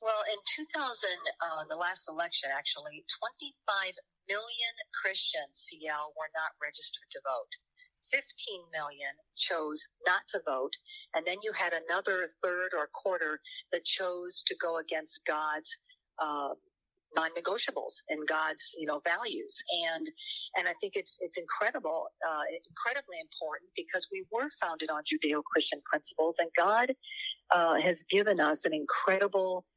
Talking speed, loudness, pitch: 140 wpm, -33 LUFS, 195 Hz